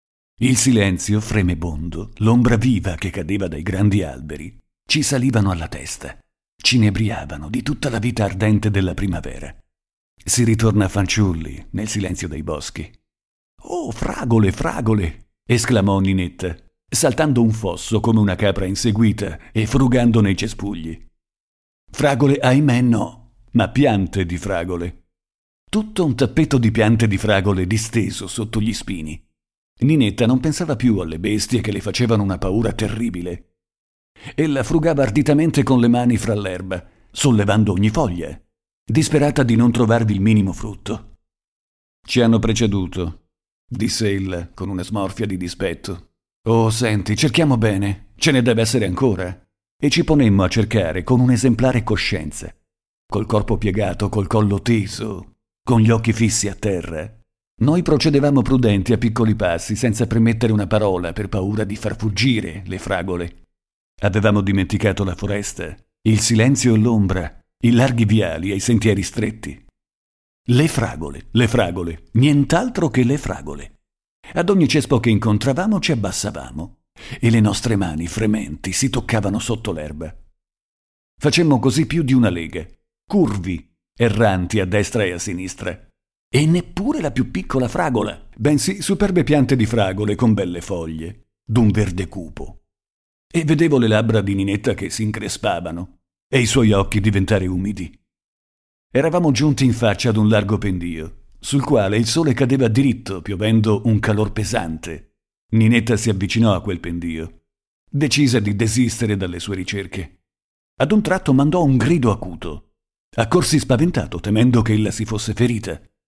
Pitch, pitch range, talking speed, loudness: 110 Hz, 95-120 Hz, 145 wpm, -18 LUFS